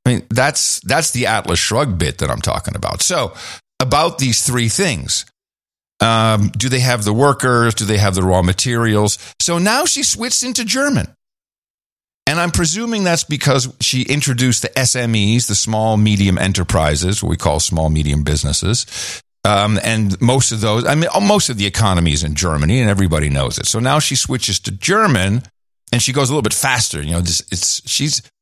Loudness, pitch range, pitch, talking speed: -15 LUFS, 100-135 Hz, 115 Hz, 190 wpm